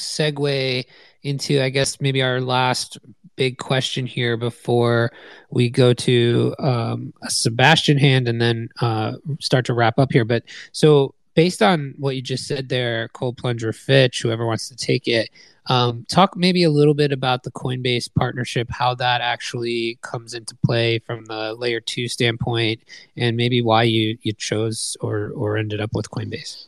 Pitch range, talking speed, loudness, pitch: 115-135 Hz, 170 wpm, -20 LUFS, 125 Hz